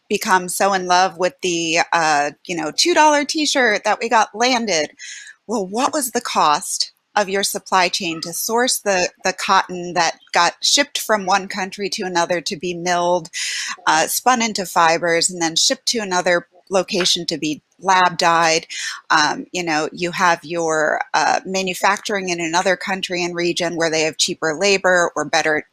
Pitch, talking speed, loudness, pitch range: 180 Hz, 175 wpm, -18 LUFS, 170-205 Hz